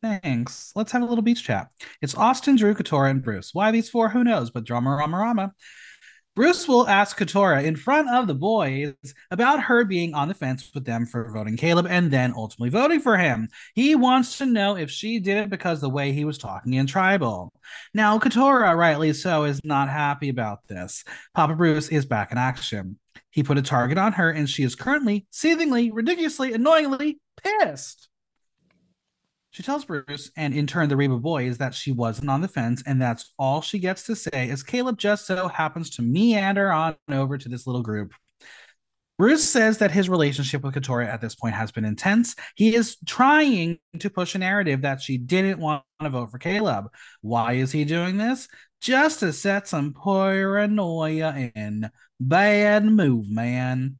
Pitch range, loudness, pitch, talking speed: 135-215 Hz, -22 LUFS, 165 Hz, 190 wpm